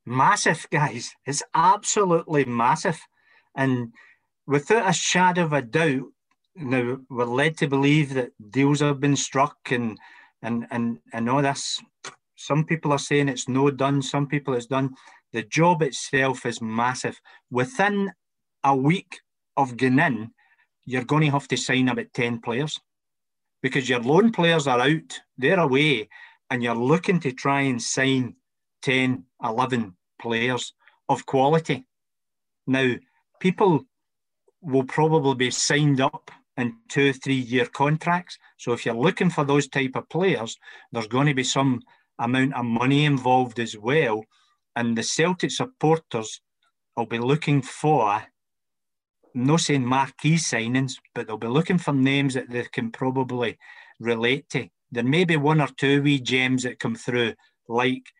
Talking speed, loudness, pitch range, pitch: 150 wpm, -23 LUFS, 125-150 Hz, 135 Hz